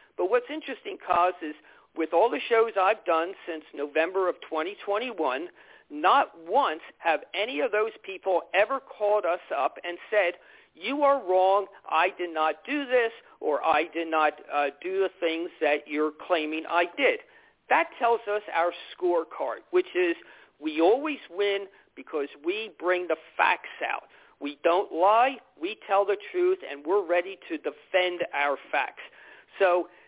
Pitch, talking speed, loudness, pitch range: 190 Hz, 160 wpm, -27 LUFS, 165-255 Hz